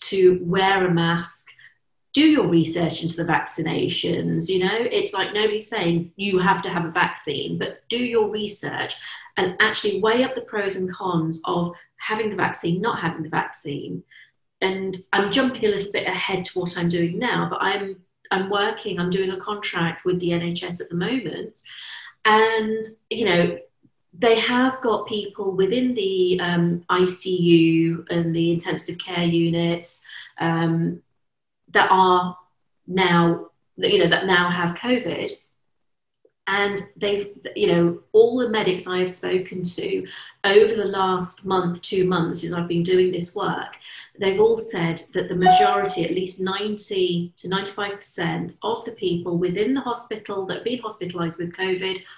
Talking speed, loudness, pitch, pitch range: 160 wpm, -22 LUFS, 185 Hz, 175-210 Hz